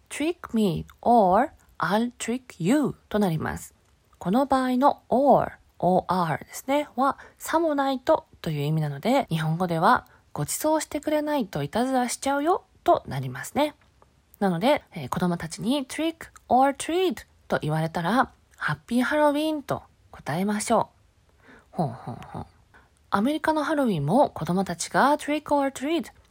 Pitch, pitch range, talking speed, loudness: 245 Hz, 180-295 Hz, 365 characters per minute, -25 LUFS